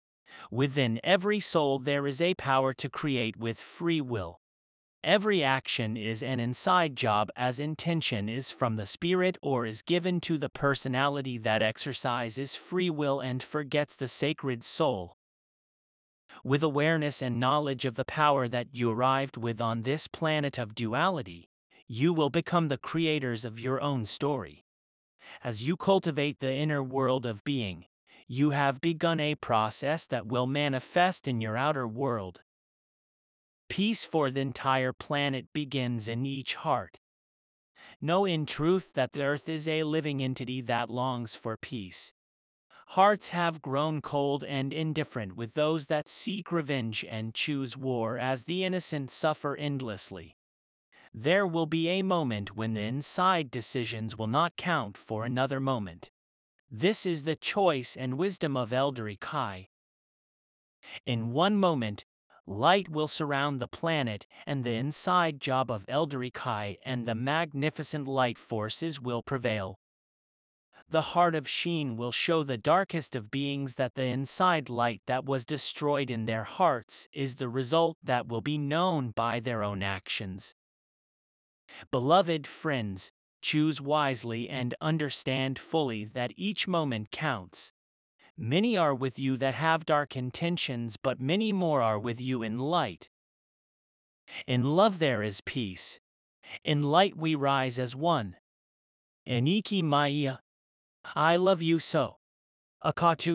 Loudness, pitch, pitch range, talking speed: -30 LUFS, 135 Hz, 120-155 Hz, 145 wpm